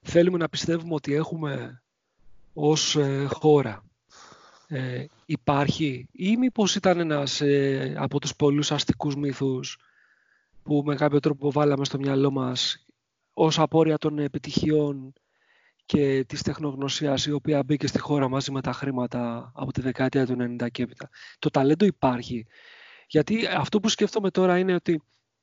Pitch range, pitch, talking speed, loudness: 135-155 Hz, 145 Hz, 145 wpm, -25 LUFS